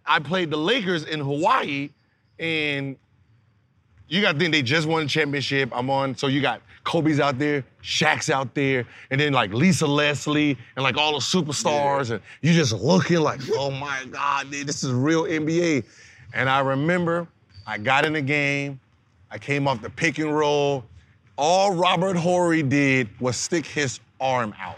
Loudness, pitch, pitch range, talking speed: -22 LUFS, 140 Hz, 125-155 Hz, 180 wpm